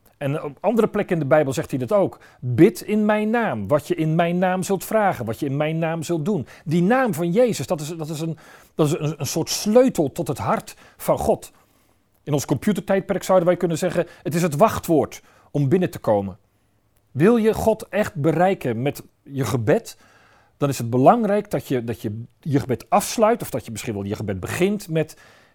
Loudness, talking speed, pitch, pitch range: -21 LUFS, 215 wpm, 160 Hz, 140-190 Hz